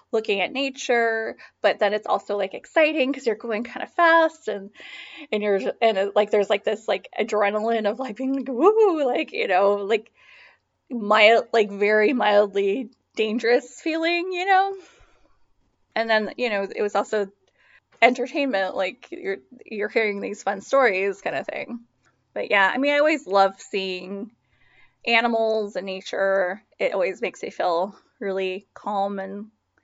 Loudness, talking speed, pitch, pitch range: -22 LUFS, 160 wpm, 220 Hz, 200-270 Hz